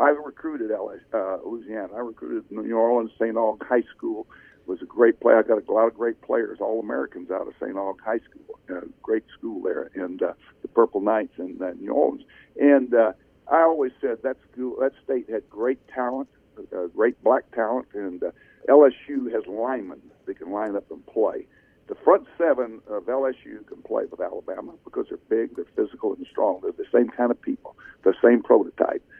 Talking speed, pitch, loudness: 200 wpm, 275 Hz, -24 LUFS